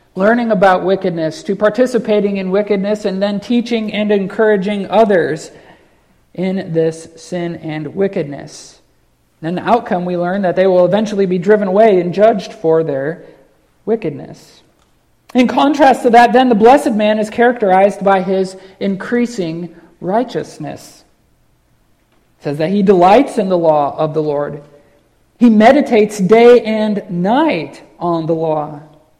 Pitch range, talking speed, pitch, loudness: 170-220 Hz, 140 wpm, 195 Hz, -13 LUFS